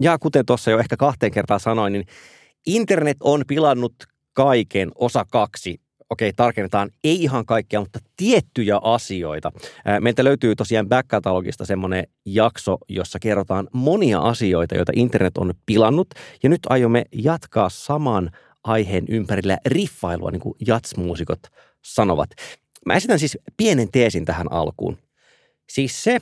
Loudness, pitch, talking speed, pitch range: -20 LUFS, 115 Hz, 135 wpm, 100-135 Hz